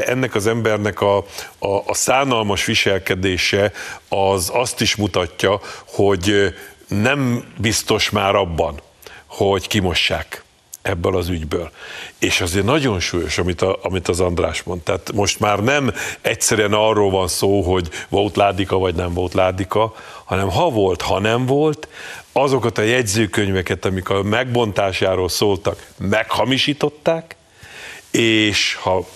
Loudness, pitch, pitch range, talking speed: -18 LUFS, 100 Hz, 95-115 Hz, 130 wpm